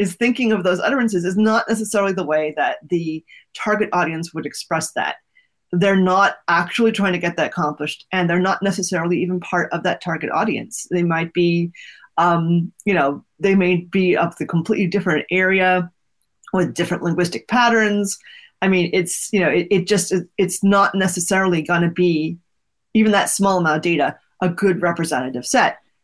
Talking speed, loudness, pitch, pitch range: 175 wpm, -19 LUFS, 180 Hz, 170-195 Hz